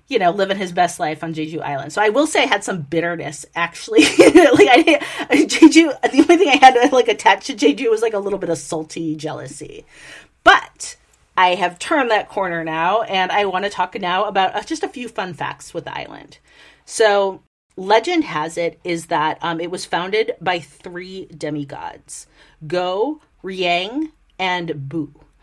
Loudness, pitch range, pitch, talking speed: -17 LUFS, 165-235 Hz, 185 Hz, 190 wpm